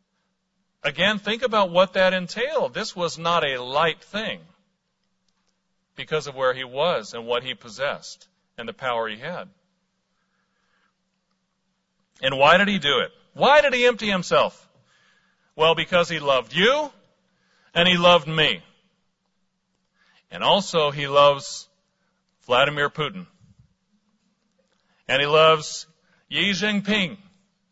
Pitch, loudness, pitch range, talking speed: 185 Hz, -21 LUFS, 165-195 Hz, 125 wpm